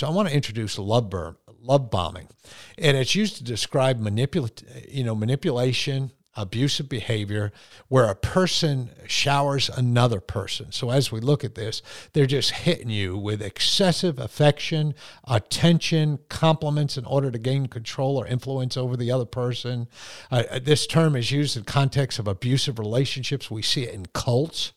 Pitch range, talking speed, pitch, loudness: 115-140 Hz, 160 wpm, 130 Hz, -24 LUFS